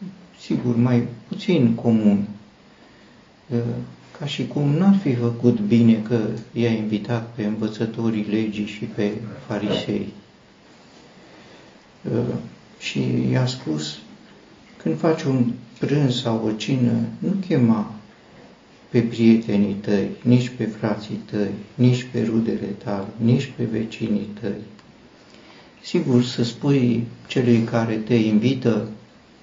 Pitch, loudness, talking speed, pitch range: 115 Hz, -22 LUFS, 110 wpm, 105-120 Hz